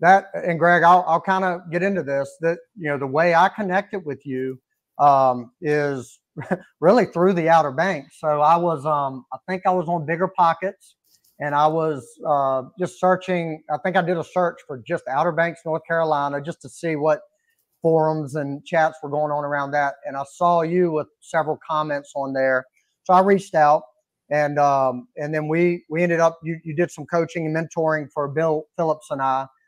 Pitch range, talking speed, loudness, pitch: 145-175 Hz, 200 wpm, -21 LUFS, 160 Hz